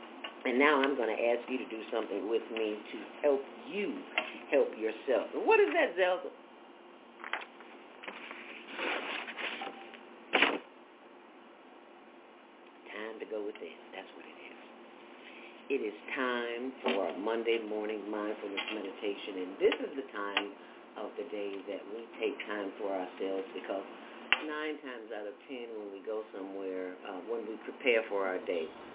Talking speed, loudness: 145 wpm, -34 LUFS